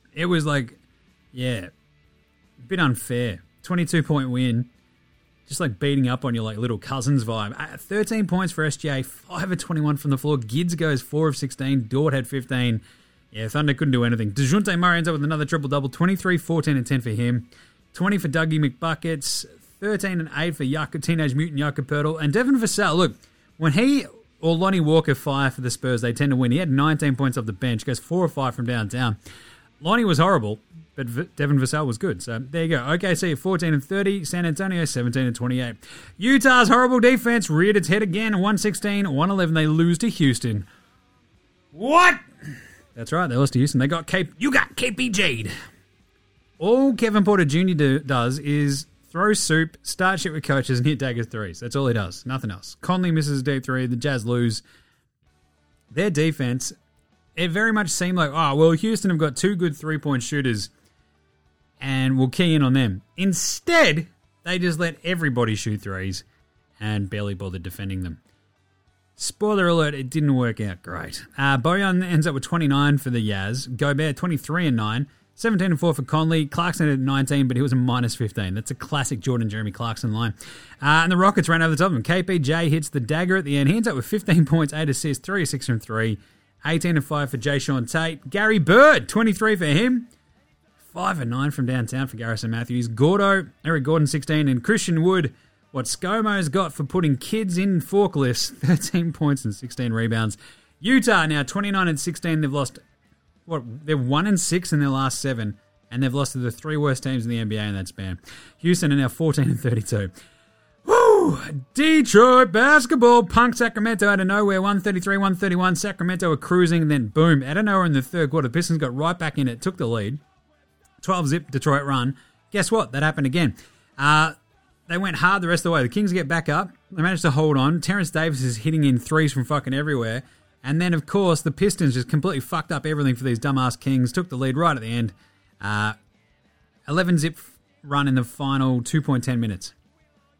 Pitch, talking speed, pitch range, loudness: 145 Hz, 195 wpm, 125-175 Hz, -21 LUFS